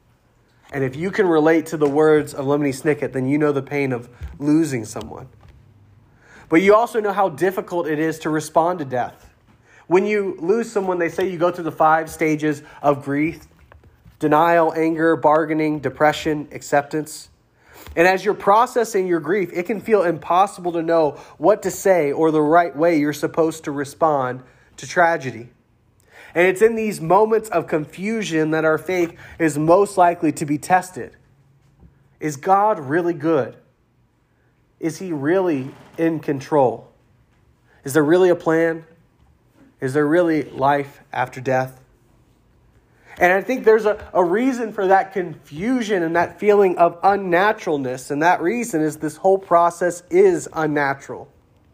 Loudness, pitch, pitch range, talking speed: -19 LUFS, 160 Hz, 145-180 Hz, 155 wpm